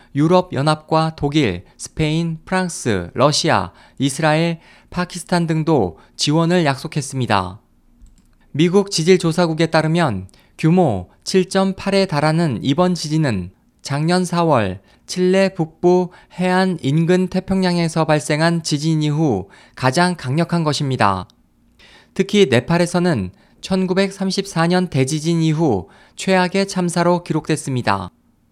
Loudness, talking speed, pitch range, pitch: -18 LUFS, 240 characters per minute, 145-180 Hz, 165 Hz